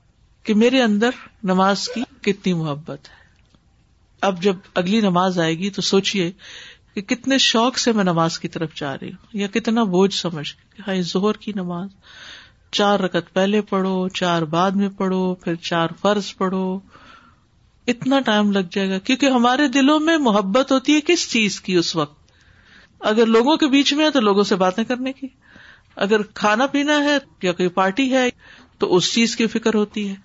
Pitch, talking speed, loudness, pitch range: 200 Hz, 180 wpm, -19 LUFS, 185-245 Hz